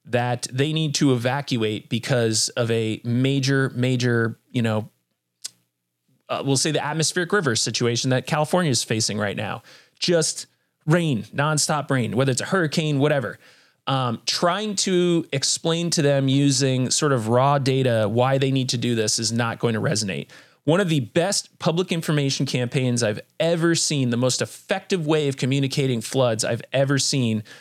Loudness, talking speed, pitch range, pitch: -22 LUFS, 165 wpm, 120-155 Hz, 135 Hz